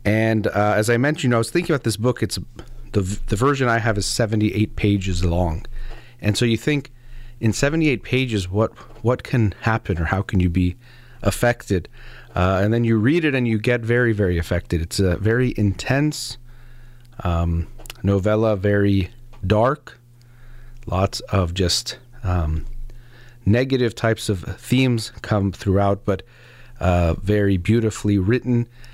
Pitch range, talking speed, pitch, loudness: 100-120 Hz, 155 wpm, 115 Hz, -21 LUFS